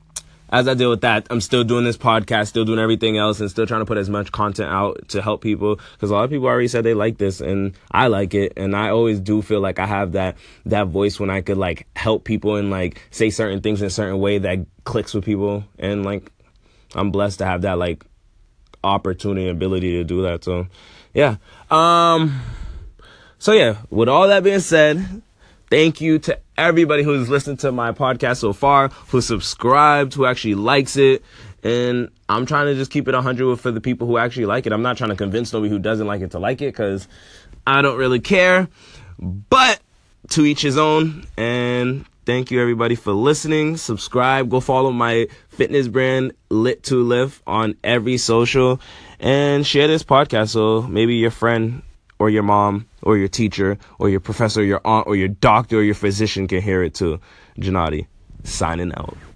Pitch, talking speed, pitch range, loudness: 110 Hz, 200 wpm, 100-125 Hz, -18 LUFS